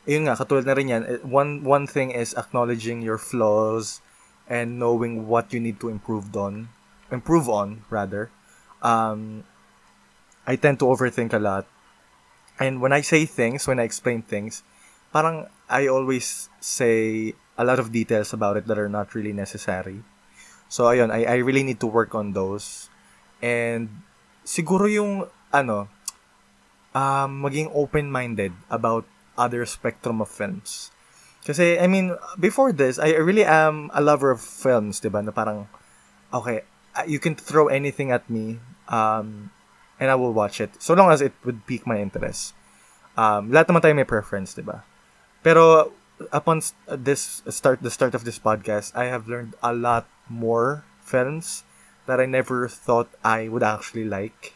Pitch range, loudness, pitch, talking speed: 105-135 Hz, -22 LUFS, 120 Hz, 160 wpm